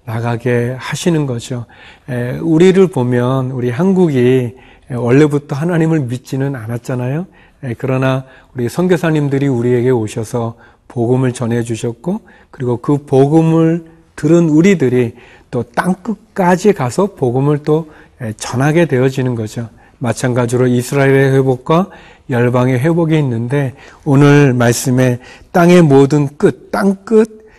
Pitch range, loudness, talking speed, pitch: 125-160 Hz, -13 LUFS, 280 characters per minute, 135 Hz